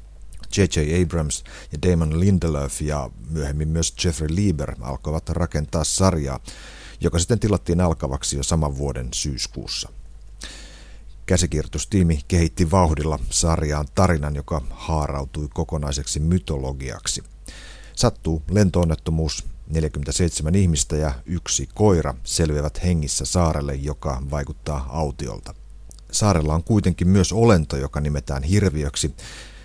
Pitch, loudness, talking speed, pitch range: 80 Hz, -22 LUFS, 105 wpm, 75-90 Hz